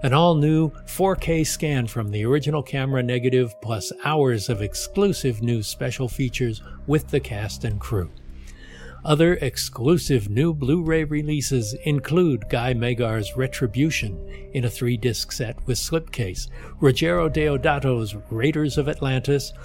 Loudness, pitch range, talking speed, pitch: -23 LUFS, 120-150 Hz, 125 wpm, 130 Hz